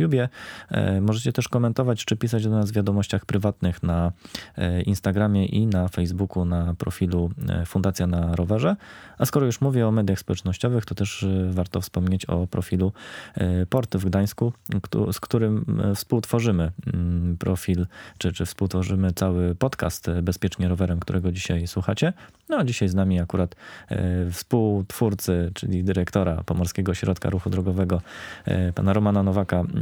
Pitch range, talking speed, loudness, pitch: 90-105 Hz, 135 wpm, -24 LUFS, 95 Hz